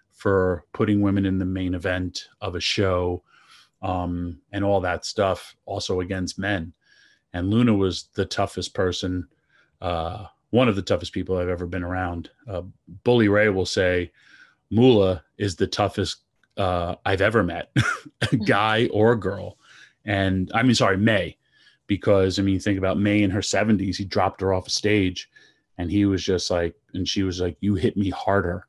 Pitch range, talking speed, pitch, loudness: 90-105 Hz, 180 wpm, 95 Hz, -23 LUFS